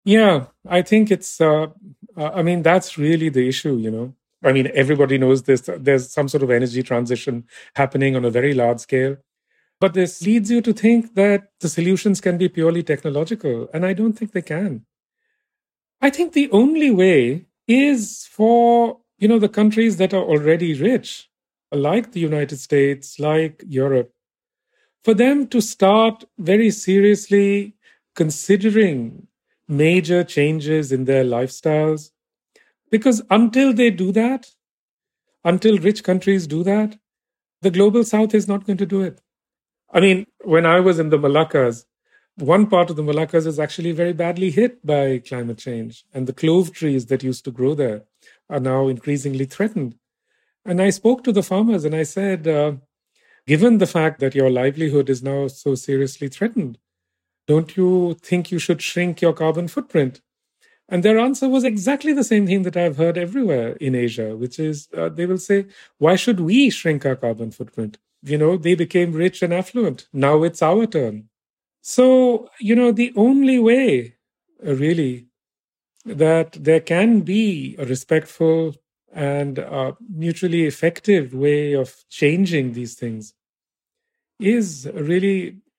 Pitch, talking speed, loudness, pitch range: 170 Hz, 160 wpm, -18 LUFS, 140-210 Hz